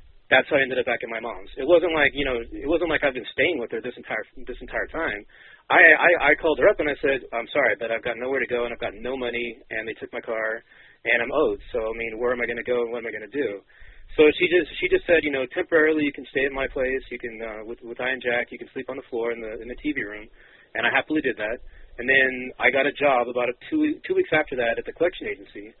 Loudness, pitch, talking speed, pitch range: -23 LUFS, 130 Hz, 300 wpm, 120-155 Hz